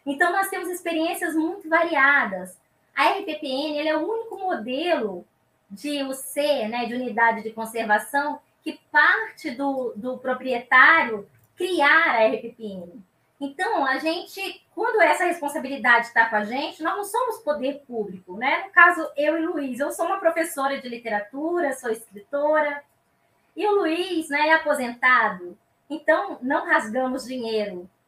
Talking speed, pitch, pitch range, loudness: 145 wpm, 285 Hz, 235-325 Hz, -22 LUFS